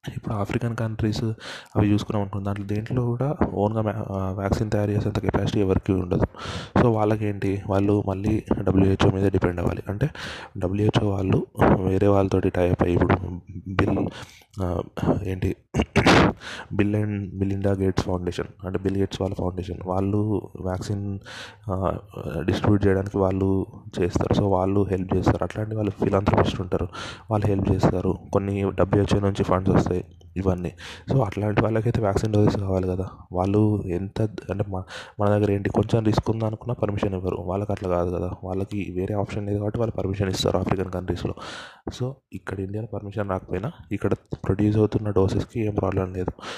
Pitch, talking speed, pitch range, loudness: 100 Hz, 145 wpm, 95-105 Hz, -24 LUFS